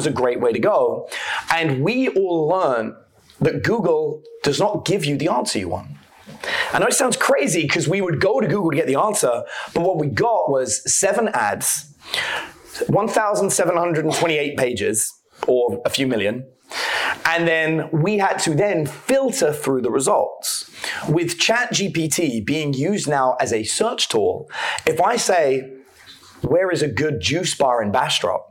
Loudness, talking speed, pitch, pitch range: -20 LUFS, 175 wpm, 165 Hz, 135-200 Hz